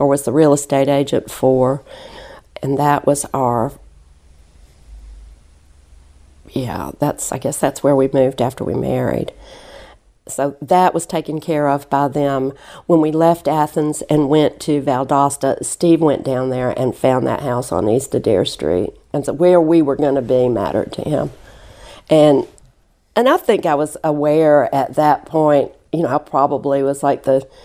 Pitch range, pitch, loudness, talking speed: 125-150 Hz, 140 Hz, -16 LUFS, 170 wpm